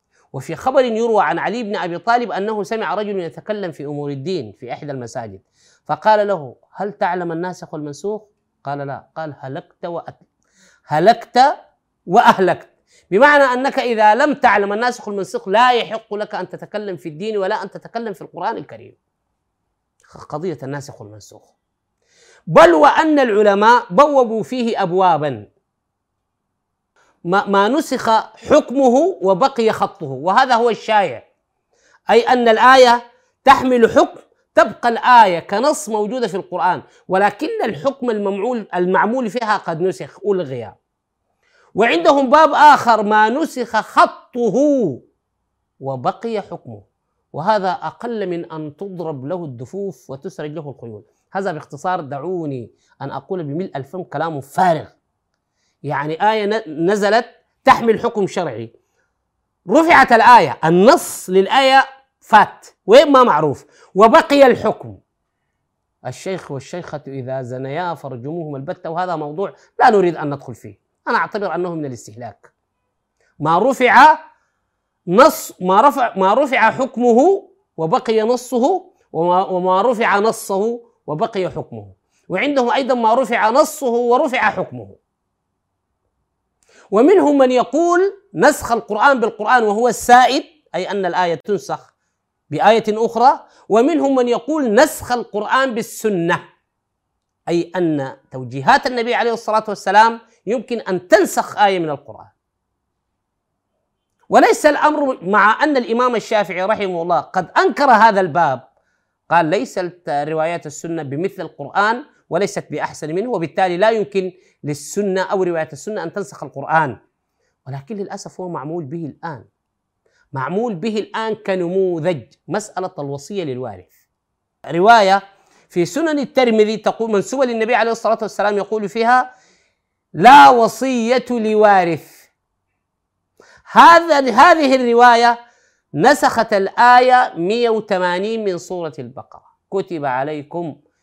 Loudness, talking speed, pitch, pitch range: -15 LUFS, 115 wpm, 200 Hz, 165-245 Hz